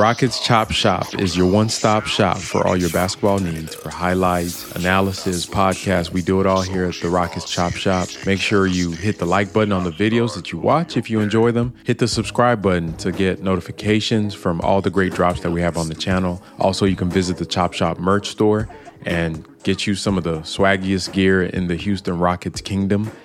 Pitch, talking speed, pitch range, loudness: 95 Hz, 215 wpm, 90-105 Hz, -19 LUFS